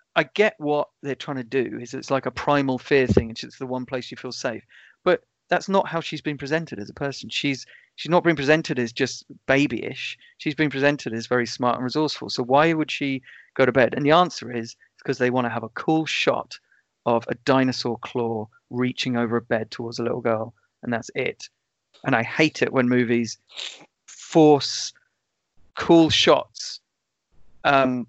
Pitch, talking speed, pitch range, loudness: 130 Hz, 195 wpm, 120-150 Hz, -23 LUFS